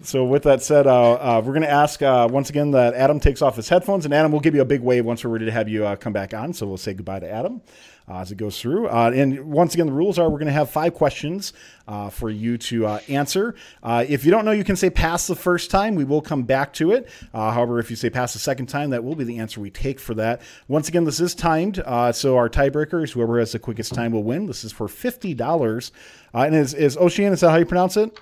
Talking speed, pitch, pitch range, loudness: 285 wpm, 135 Hz, 115-160 Hz, -20 LUFS